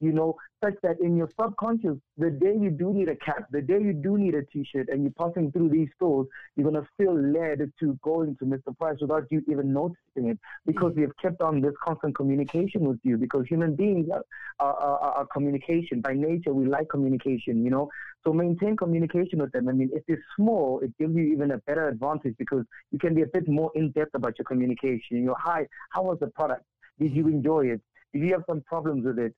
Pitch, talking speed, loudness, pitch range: 155 Hz, 235 wpm, -27 LUFS, 140-170 Hz